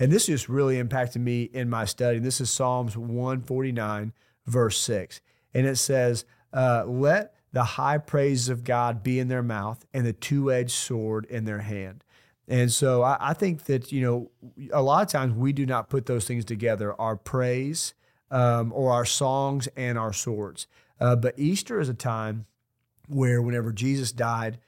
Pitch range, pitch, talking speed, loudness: 115-135 Hz, 125 Hz, 180 wpm, -26 LUFS